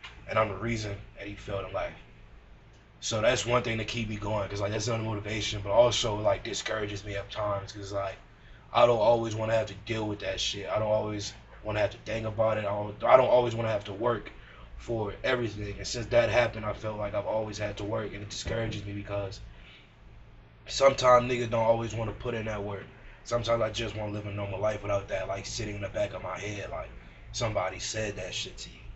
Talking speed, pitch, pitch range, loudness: 240 wpm, 105 Hz, 100-115 Hz, -30 LUFS